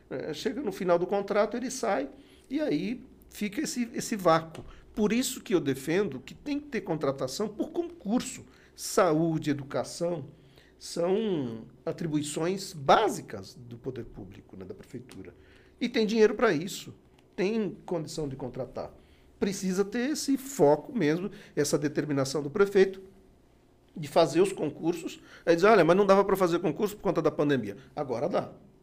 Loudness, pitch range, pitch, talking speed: -28 LUFS, 145-220 Hz, 180 Hz, 150 wpm